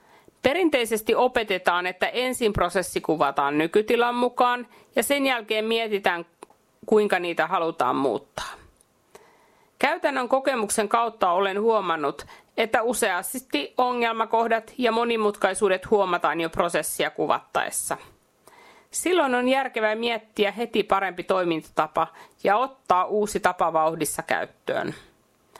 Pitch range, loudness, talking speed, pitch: 185-240 Hz, -24 LUFS, 100 wpm, 215 Hz